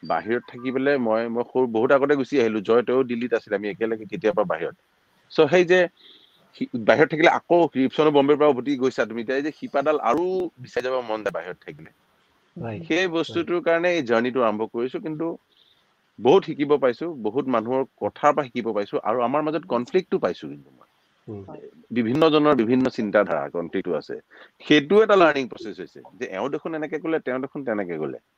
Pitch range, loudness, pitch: 120-160 Hz, -22 LUFS, 140 Hz